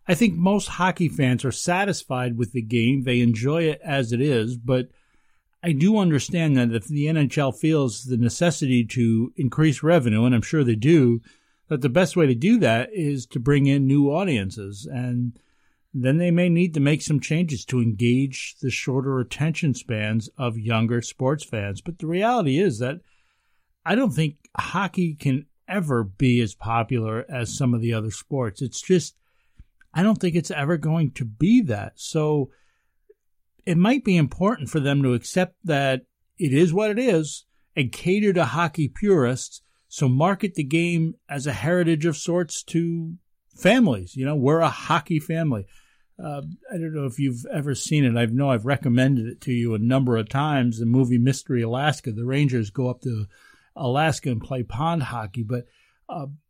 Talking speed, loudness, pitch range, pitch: 180 wpm, -22 LUFS, 125-165 Hz, 140 Hz